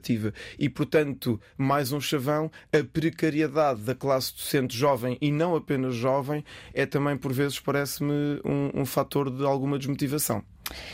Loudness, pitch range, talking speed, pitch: -27 LUFS, 130-150 Hz, 145 wpm, 140 Hz